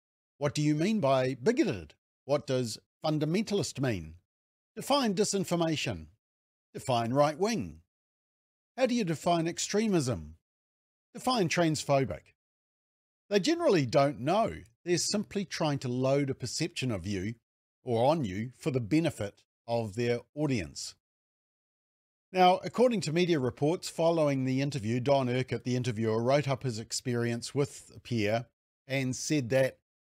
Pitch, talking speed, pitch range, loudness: 135 Hz, 130 wpm, 115-170 Hz, -30 LUFS